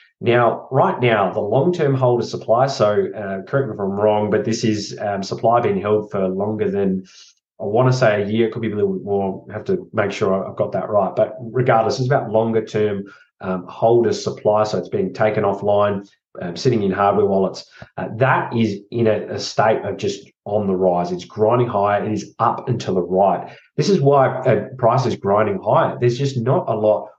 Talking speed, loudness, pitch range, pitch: 210 wpm, -19 LUFS, 100-125 Hz, 105 Hz